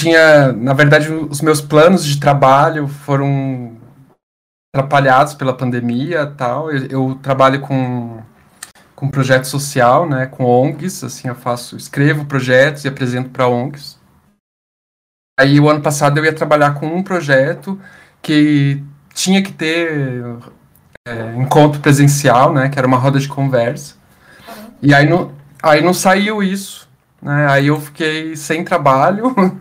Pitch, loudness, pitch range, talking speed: 140 Hz, -13 LUFS, 130-155 Hz, 140 wpm